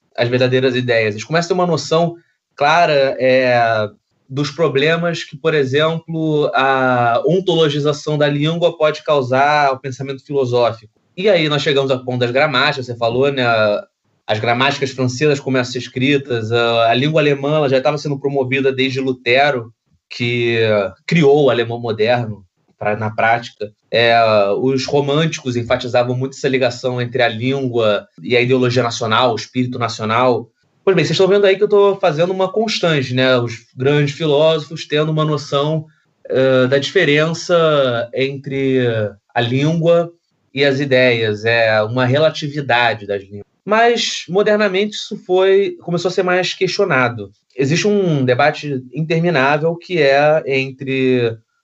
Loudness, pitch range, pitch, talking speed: -16 LUFS, 120-155 Hz, 135 Hz, 145 wpm